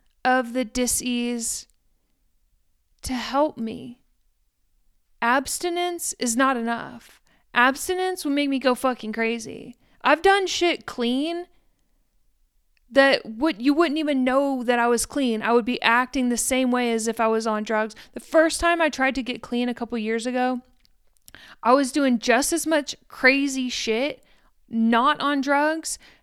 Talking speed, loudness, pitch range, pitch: 155 wpm, -22 LUFS, 235-285 Hz, 255 Hz